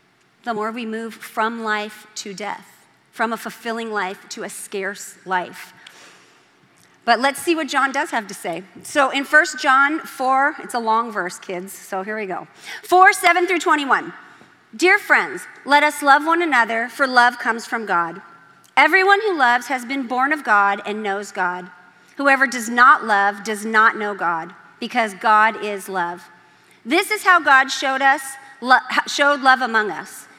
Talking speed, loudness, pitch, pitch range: 175 wpm, -18 LUFS, 235 Hz, 205-275 Hz